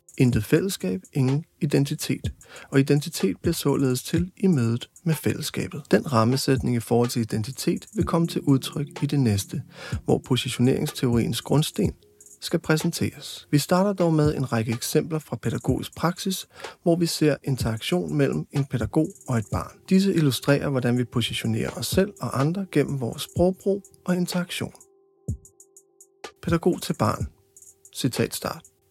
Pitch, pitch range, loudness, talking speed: 145 Hz, 120-175 Hz, -24 LUFS, 145 wpm